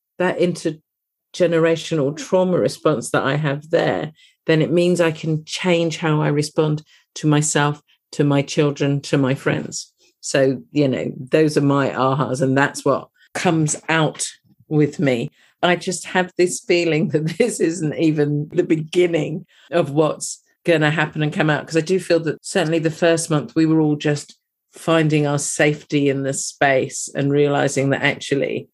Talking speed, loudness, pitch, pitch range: 170 wpm, -19 LUFS, 155 Hz, 145-165 Hz